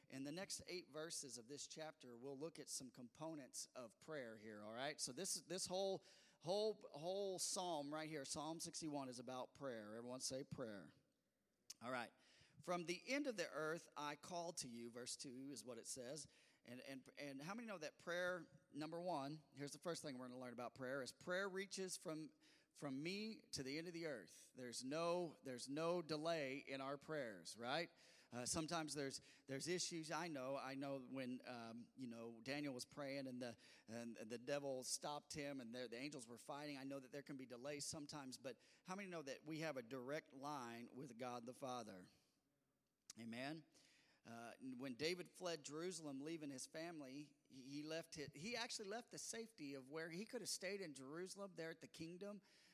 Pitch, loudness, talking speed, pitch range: 145 Hz, -51 LUFS, 200 wpm, 130-170 Hz